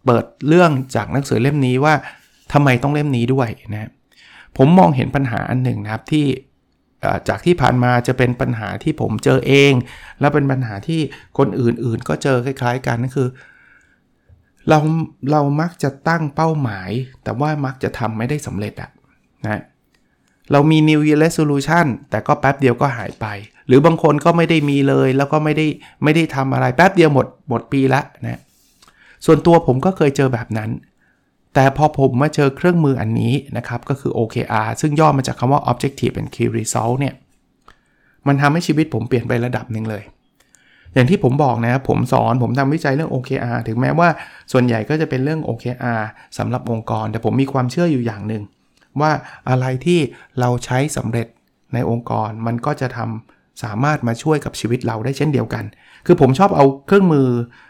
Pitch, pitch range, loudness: 130 Hz, 120-150 Hz, -17 LUFS